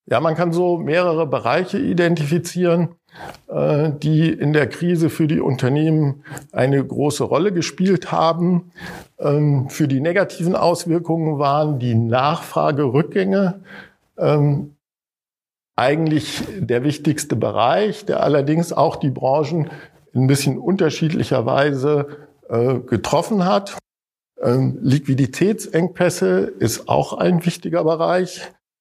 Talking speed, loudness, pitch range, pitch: 100 wpm, -19 LUFS, 145-175 Hz, 155 Hz